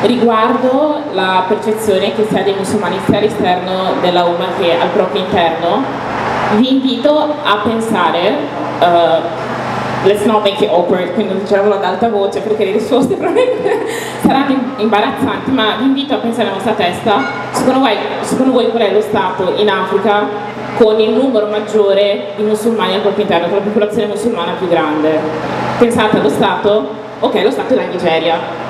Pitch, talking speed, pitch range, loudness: 210 Hz, 165 wpm, 195-230 Hz, -13 LUFS